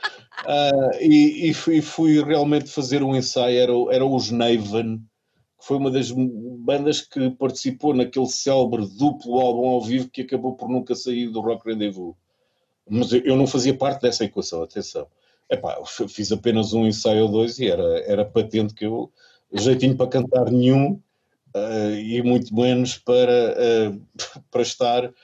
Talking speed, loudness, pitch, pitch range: 170 wpm, -21 LUFS, 125 Hz, 115-135 Hz